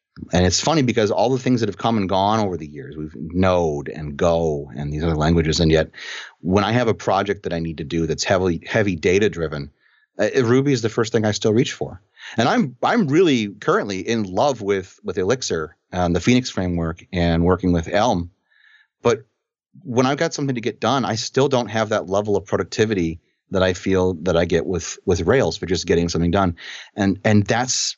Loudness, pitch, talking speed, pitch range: -20 LUFS, 95 Hz, 210 wpm, 85-115 Hz